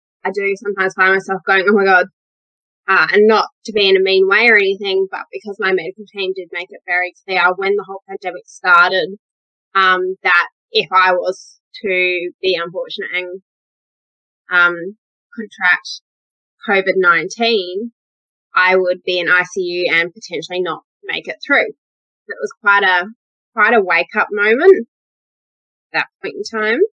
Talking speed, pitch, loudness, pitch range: 160 wpm, 195 Hz, -15 LUFS, 180-230 Hz